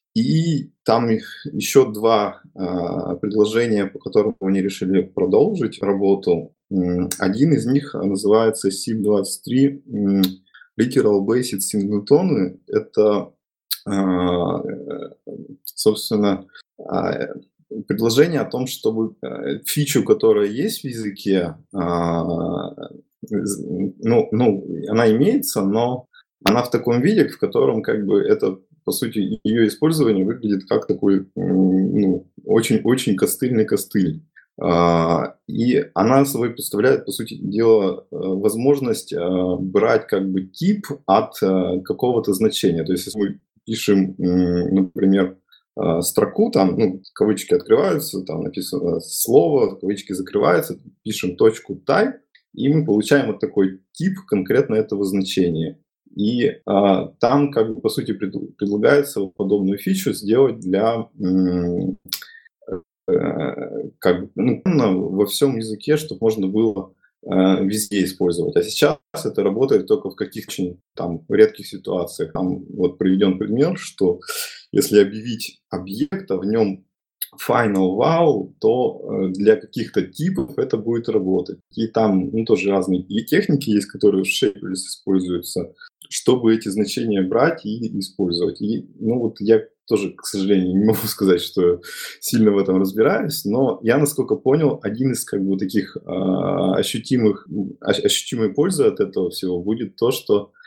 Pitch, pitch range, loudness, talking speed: 105 Hz, 95-125 Hz, -20 LUFS, 125 wpm